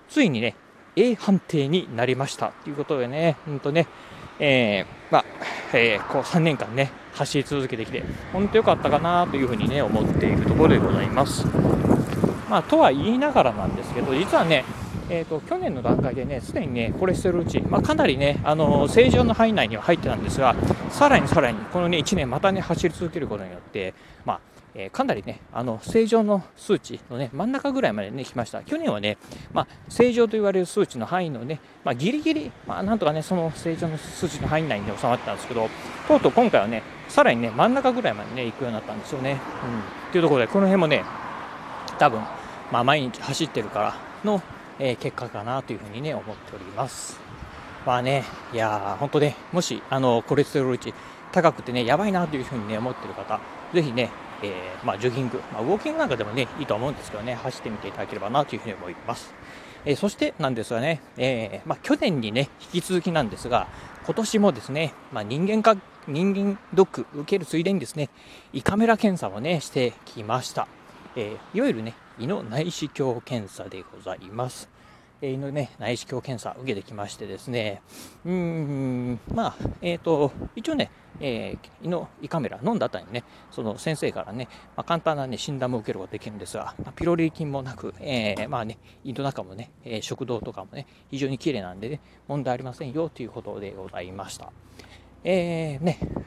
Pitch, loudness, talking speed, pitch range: 145 Hz, -24 LUFS, 395 characters per minute, 120-175 Hz